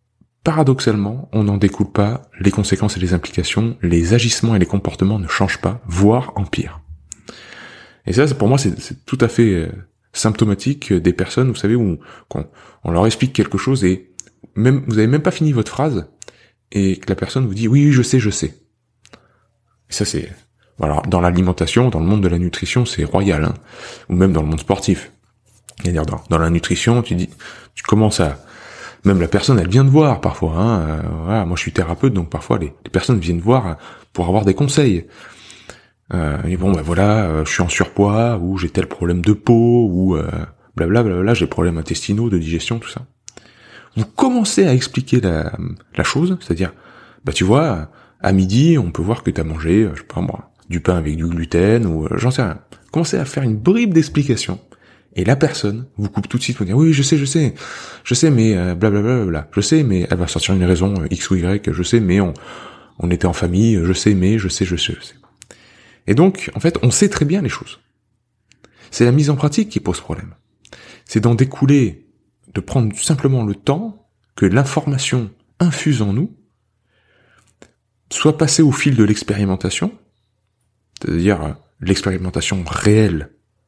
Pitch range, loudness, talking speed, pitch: 90-125 Hz, -17 LUFS, 200 wpm, 105 Hz